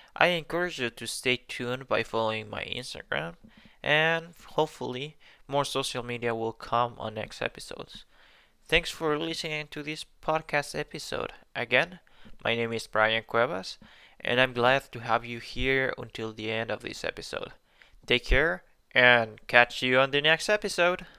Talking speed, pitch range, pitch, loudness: 155 wpm, 115-150 Hz, 125 Hz, -28 LUFS